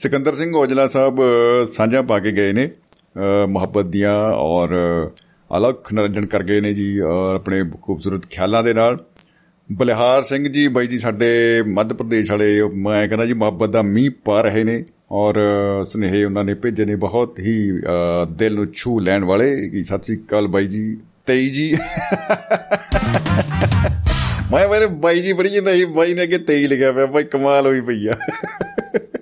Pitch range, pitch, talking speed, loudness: 100-135 Hz, 110 Hz, 160 wpm, -17 LUFS